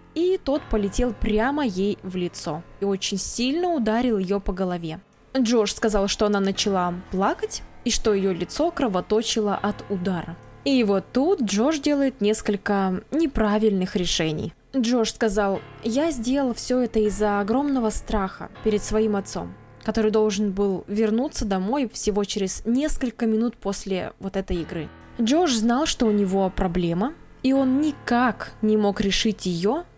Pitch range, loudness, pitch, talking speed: 195-245 Hz, -23 LUFS, 215 Hz, 145 wpm